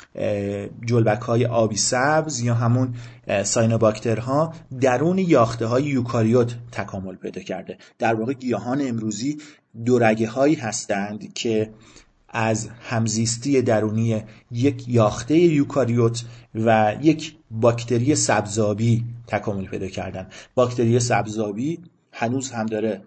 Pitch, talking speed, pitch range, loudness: 115 Hz, 105 wpm, 110-125 Hz, -22 LUFS